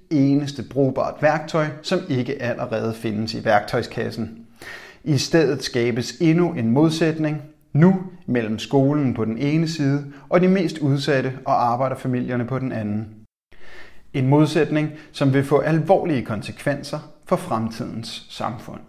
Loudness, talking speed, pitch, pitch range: -21 LUFS, 130 wpm, 140 Hz, 120-155 Hz